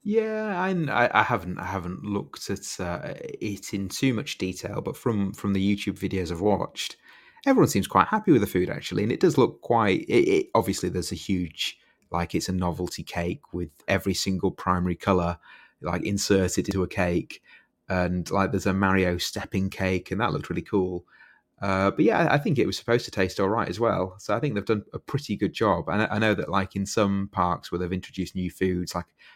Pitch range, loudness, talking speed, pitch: 90-105 Hz, -26 LUFS, 220 wpm, 95 Hz